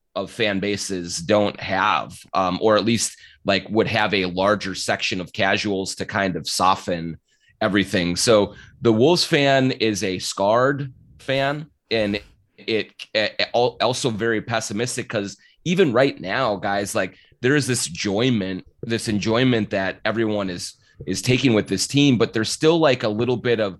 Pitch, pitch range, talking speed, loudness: 110 Hz, 100-125 Hz, 165 wpm, -21 LUFS